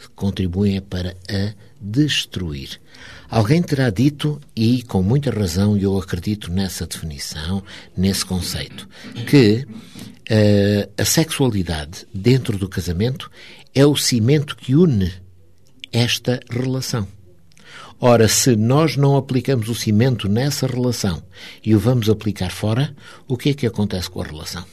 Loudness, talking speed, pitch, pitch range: -19 LUFS, 130 wpm, 110 Hz, 95-130 Hz